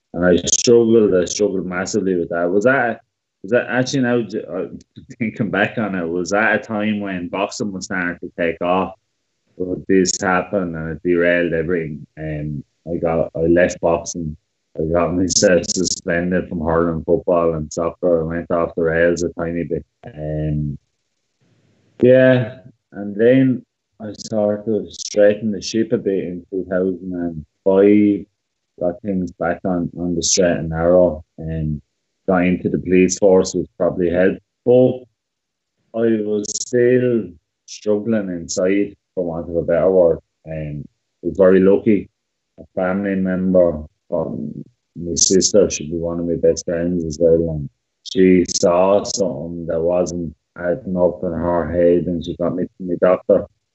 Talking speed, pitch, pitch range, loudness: 160 wpm, 90 Hz, 85-100 Hz, -18 LUFS